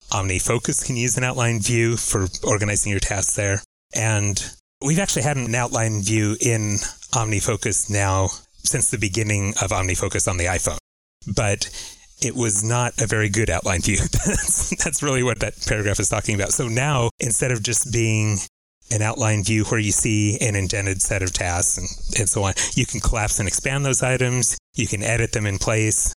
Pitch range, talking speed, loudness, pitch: 100-120 Hz, 185 wpm, -21 LUFS, 110 Hz